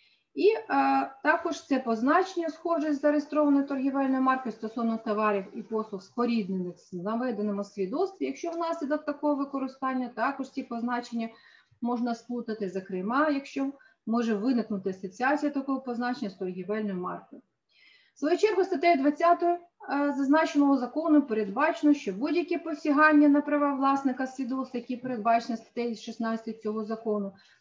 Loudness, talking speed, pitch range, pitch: -28 LUFS, 130 wpm, 225-300 Hz, 265 Hz